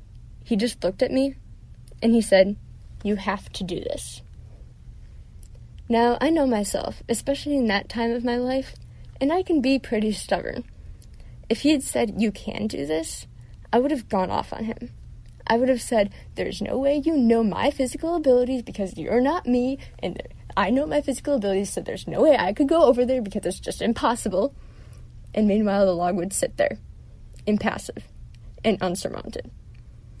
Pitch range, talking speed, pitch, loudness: 200-265 Hz, 180 wpm, 230 Hz, -24 LUFS